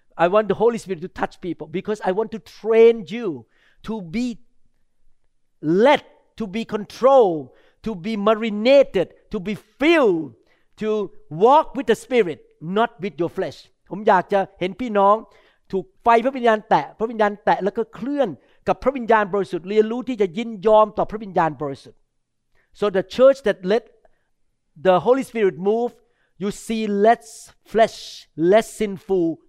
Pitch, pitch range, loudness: 215 Hz, 195-230 Hz, -20 LUFS